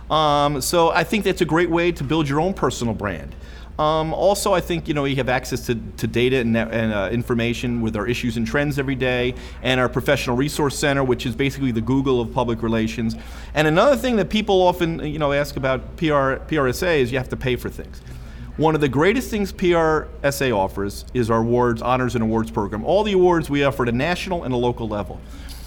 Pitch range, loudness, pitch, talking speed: 115-155 Hz, -20 LUFS, 130 Hz, 220 wpm